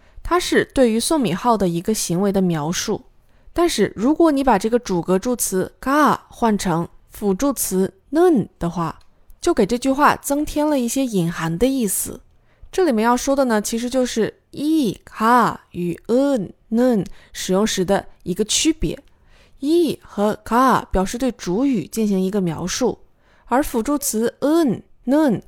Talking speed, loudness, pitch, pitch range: 255 characters per minute, -19 LUFS, 230 Hz, 190-275 Hz